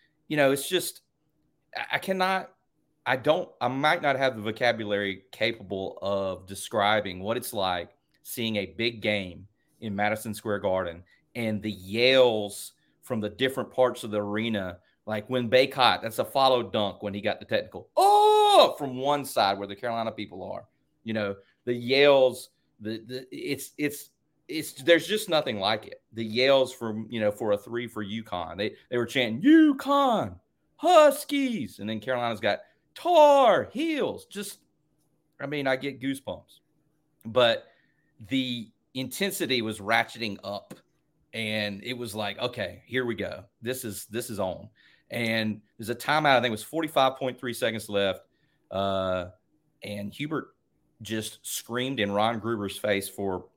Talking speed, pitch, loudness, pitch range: 160 wpm, 120 Hz, -26 LUFS, 105-140 Hz